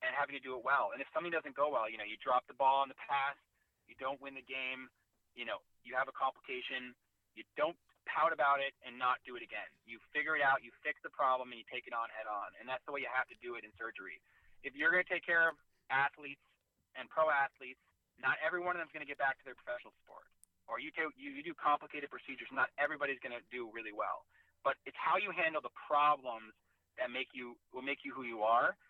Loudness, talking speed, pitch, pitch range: -37 LUFS, 255 wpm, 140 Hz, 130-150 Hz